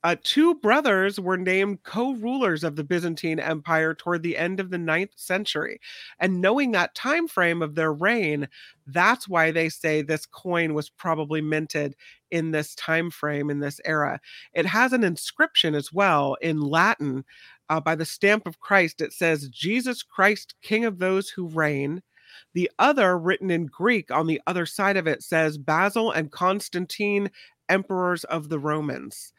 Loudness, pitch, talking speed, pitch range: -24 LUFS, 170 Hz, 170 wpm, 155-195 Hz